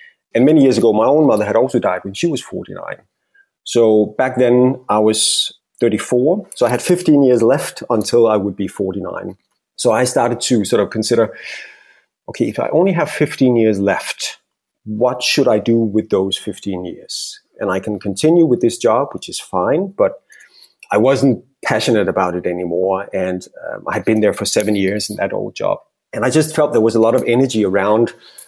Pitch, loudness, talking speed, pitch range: 115 Hz, -16 LUFS, 200 wpm, 105-135 Hz